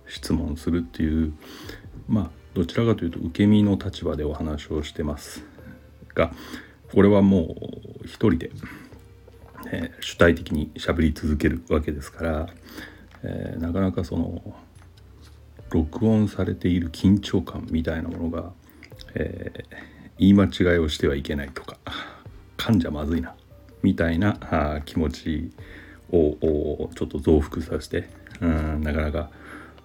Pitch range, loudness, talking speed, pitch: 80-95 Hz, -24 LUFS, 270 characters per minute, 85 Hz